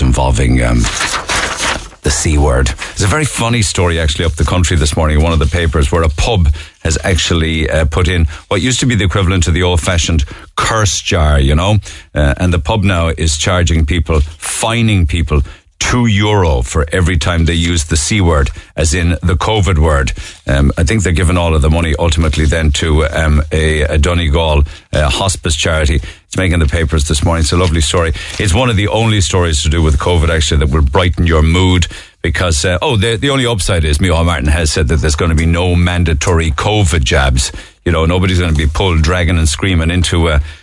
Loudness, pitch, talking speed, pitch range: -13 LUFS, 85 Hz, 210 wpm, 80-90 Hz